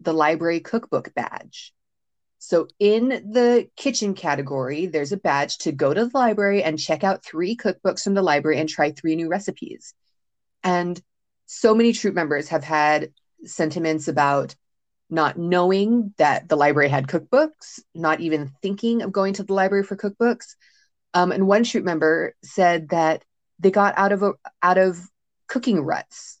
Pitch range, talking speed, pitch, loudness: 160-210 Hz, 165 wpm, 185 Hz, -21 LUFS